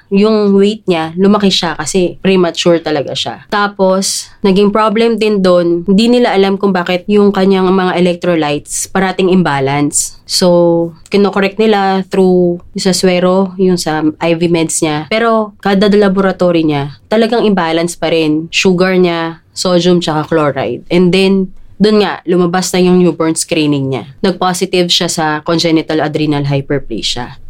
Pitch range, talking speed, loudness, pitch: 165-195 Hz, 145 wpm, -11 LUFS, 180 Hz